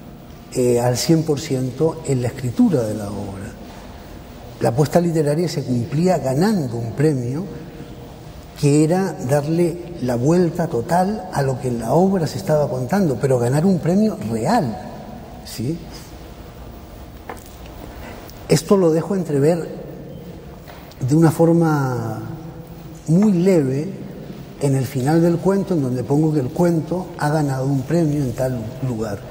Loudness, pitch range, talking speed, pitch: -19 LUFS, 130-170 Hz, 135 wpm, 155 Hz